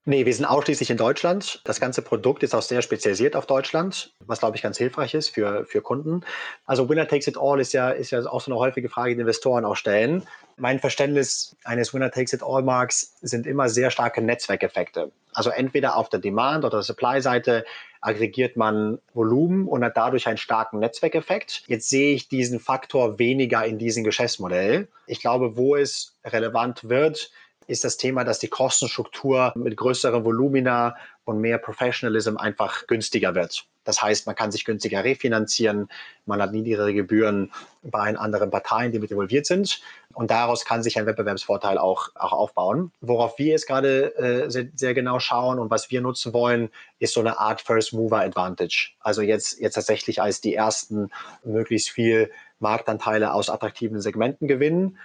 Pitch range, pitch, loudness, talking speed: 110-135 Hz, 120 Hz, -23 LUFS, 180 wpm